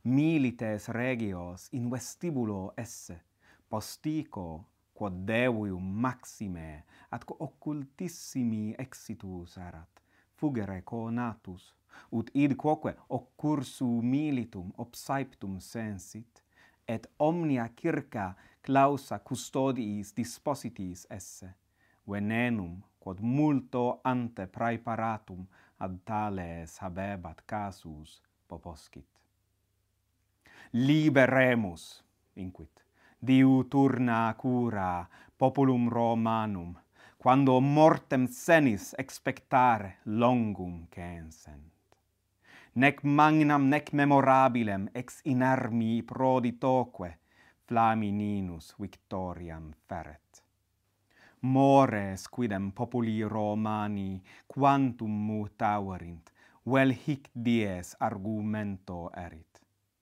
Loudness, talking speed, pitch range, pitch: -29 LUFS, 70 wpm, 95-130 Hz, 110 Hz